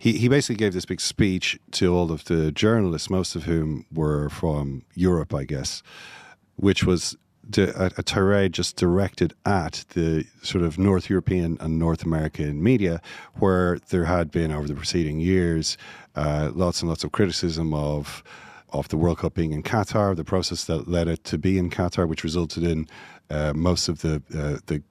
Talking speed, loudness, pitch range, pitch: 190 wpm, -24 LUFS, 80-95 Hz, 85 Hz